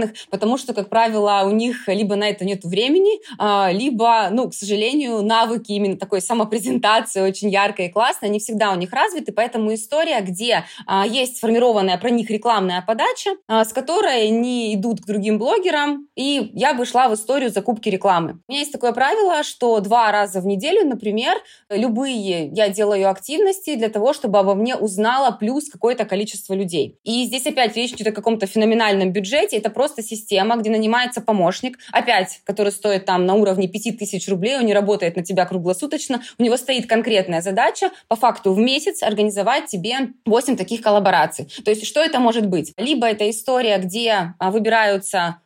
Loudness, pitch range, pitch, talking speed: -19 LUFS, 200-245 Hz, 220 Hz, 175 wpm